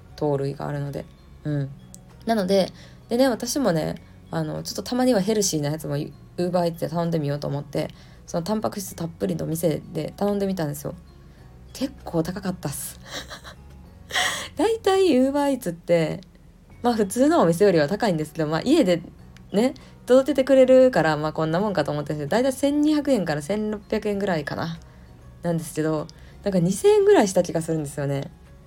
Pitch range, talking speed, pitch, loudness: 145-220 Hz, 330 characters per minute, 170 Hz, -23 LUFS